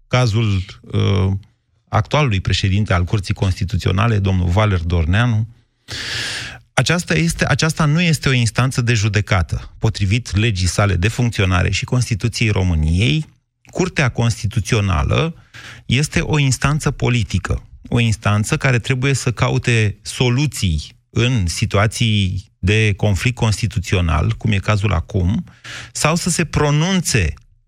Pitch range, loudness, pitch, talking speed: 100-125 Hz, -18 LUFS, 115 Hz, 115 wpm